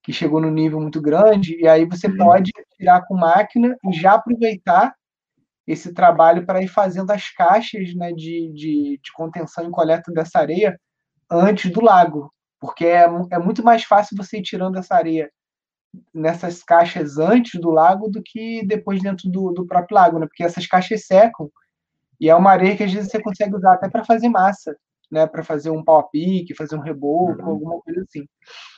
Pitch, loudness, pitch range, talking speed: 180 Hz, -17 LUFS, 160-205 Hz, 190 wpm